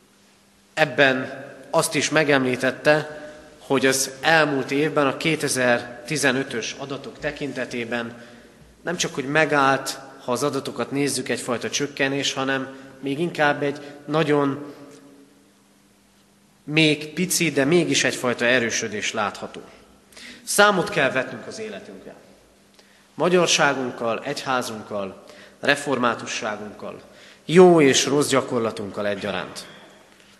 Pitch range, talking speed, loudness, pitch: 130-150 Hz, 95 wpm, -21 LUFS, 140 Hz